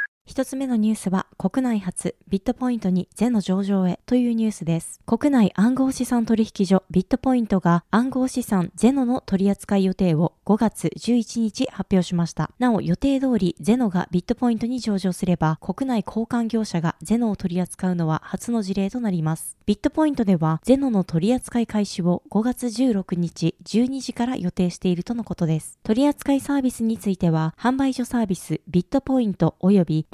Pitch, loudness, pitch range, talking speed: 210 Hz, -22 LUFS, 180-245 Hz, 365 characters per minute